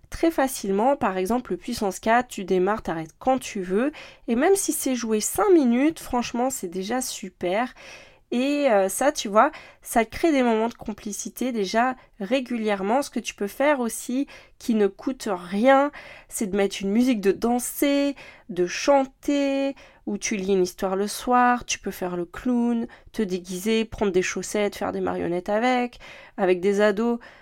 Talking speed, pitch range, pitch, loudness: 175 wpm, 200-265 Hz, 230 Hz, -24 LUFS